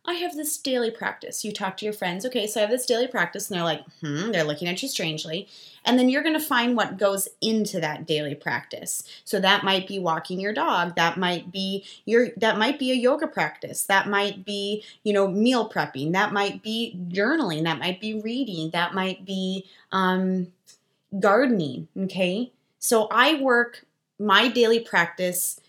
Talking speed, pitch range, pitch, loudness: 190 wpm, 180-230 Hz, 200 Hz, -24 LUFS